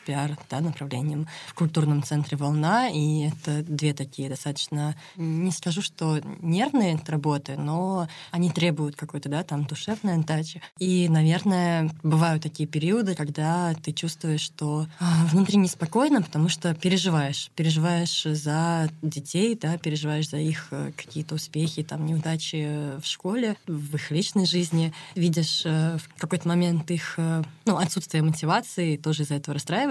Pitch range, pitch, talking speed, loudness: 150-175 Hz, 160 Hz, 135 wpm, -26 LUFS